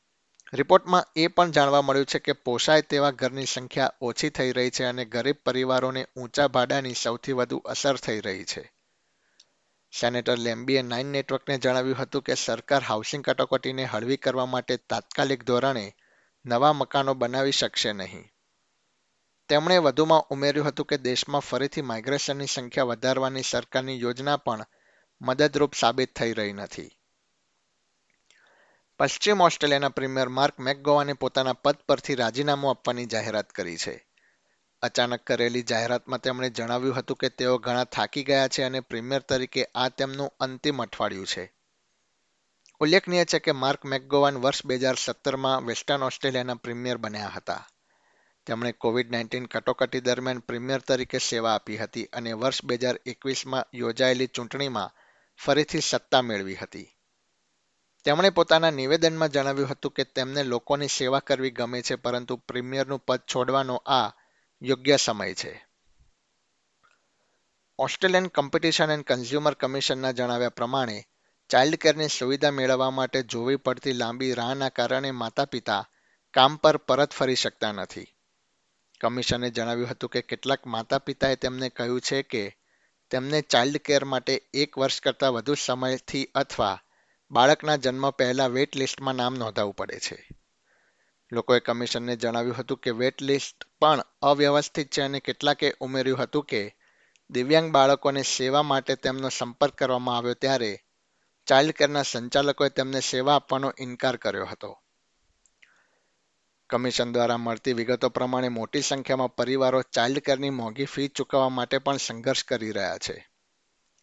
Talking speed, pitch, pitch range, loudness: 135 wpm, 130 Hz, 125-140 Hz, -25 LUFS